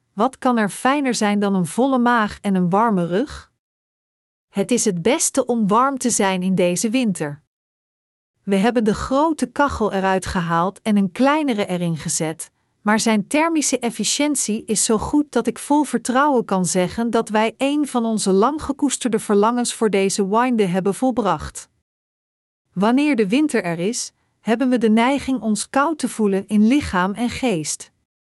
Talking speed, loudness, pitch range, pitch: 165 wpm, -19 LUFS, 195-255 Hz, 225 Hz